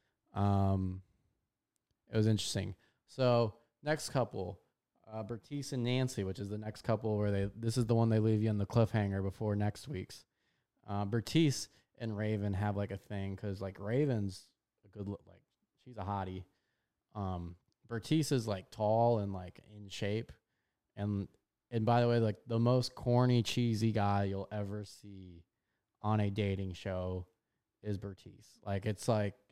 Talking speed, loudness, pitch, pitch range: 165 wpm, -35 LUFS, 105 Hz, 100-115 Hz